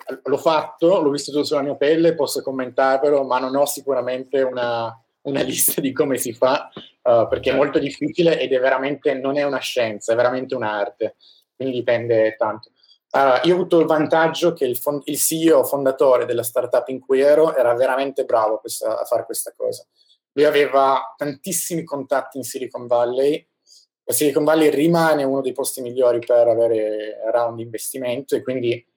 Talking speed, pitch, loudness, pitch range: 180 wpm, 135 Hz, -19 LUFS, 125-150 Hz